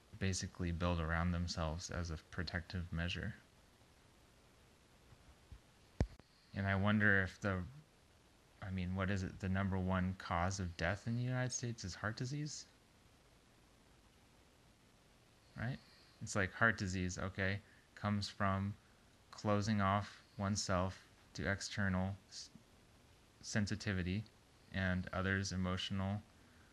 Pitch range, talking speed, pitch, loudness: 90-105 Hz, 110 wpm, 95 Hz, -40 LUFS